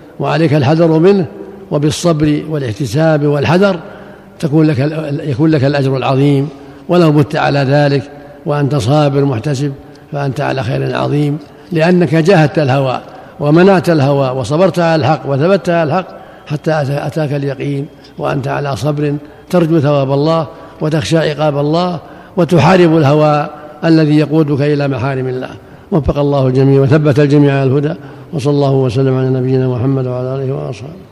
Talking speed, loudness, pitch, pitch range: 135 wpm, -12 LUFS, 150 Hz, 140-160 Hz